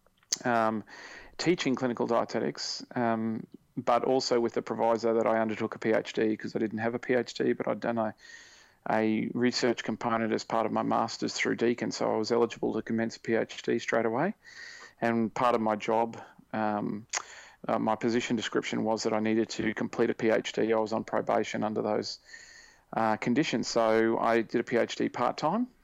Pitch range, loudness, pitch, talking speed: 110-120 Hz, -29 LUFS, 115 Hz, 180 wpm